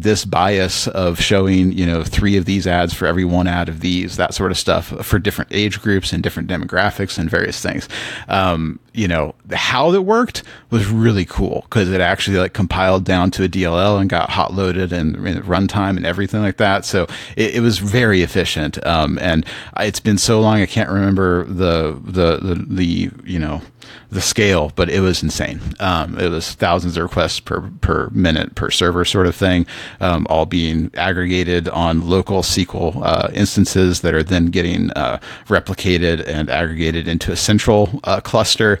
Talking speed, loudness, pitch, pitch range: 190 wpm, -17 LUFS, 95 Hz, 85-100 Hz